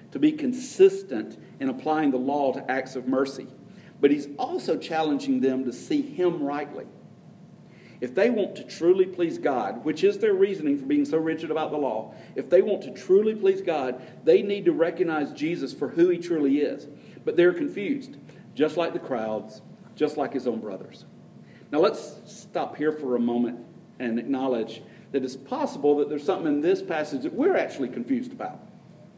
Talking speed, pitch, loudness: 185 wpm, 165 Hz, -26 LUFS